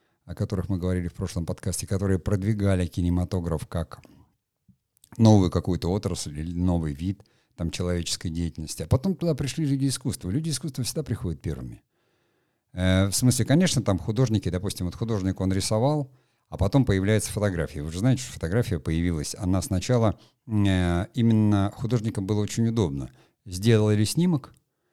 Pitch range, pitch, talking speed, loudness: 90-115 Hz, 100 Hz, 150 wpm, -25 LUFS